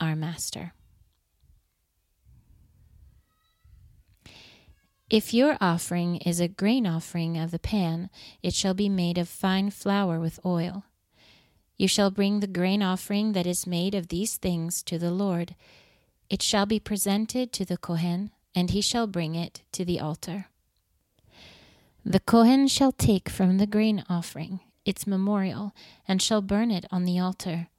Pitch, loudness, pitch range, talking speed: 180 Hz, -26 LUFS, 165-200 Hz, 145 wpm